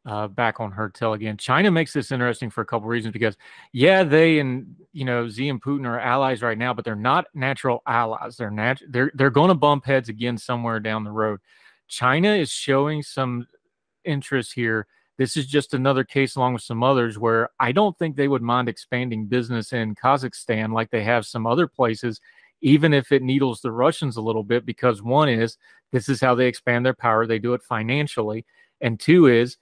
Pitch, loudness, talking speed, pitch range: 125 Hz, -22 LUFS, 210 wpm, 115-140 Hz